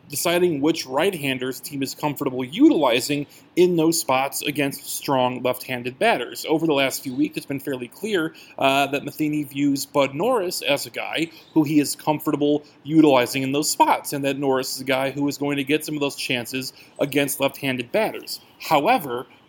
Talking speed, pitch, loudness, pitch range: 180 wpm, 145 Hz, -22 LUFS, 135-155 Hz